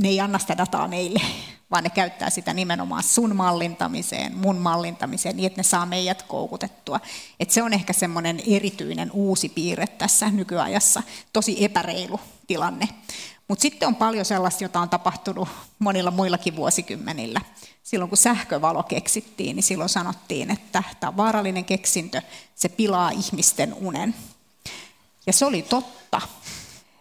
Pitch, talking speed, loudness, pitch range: 195 Hz, 140 wpm, -23 LUFS, 180-210 Hz